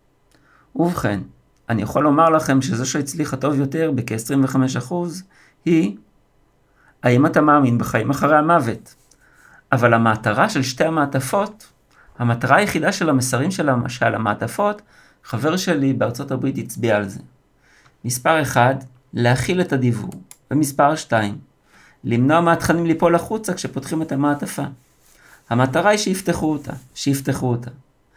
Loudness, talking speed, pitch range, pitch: -19 LUFS, 120 wpm, 125-160 Hz, 140 Hz